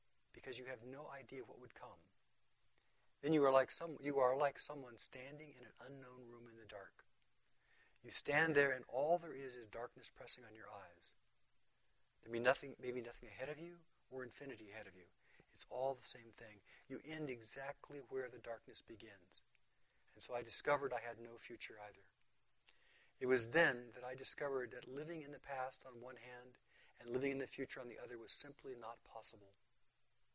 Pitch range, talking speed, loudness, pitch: 120-140 Hz, 195 wpm, -43 LUFS, 130 Hz